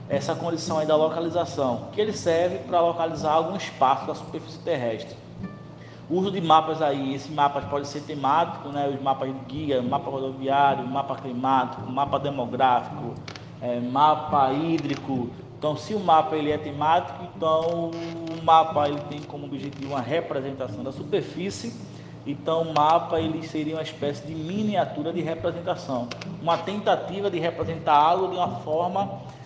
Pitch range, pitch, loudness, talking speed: 140-165 Hz, 155 Hz, -25 LUFS, 155 wpm